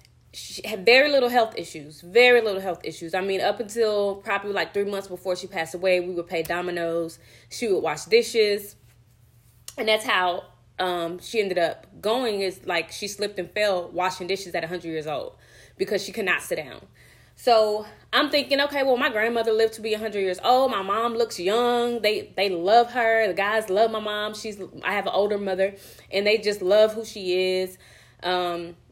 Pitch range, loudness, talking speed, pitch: 180-225 Hz, -24 LUFS, 200 wpm, 200 Hz